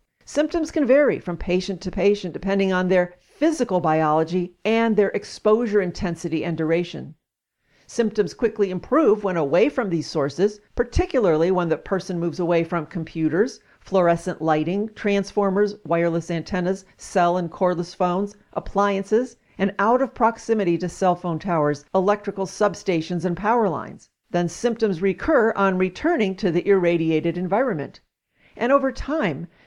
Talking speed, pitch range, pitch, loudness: 140 wpm, 170-210 Hz, 190 Hz, -22 LUFS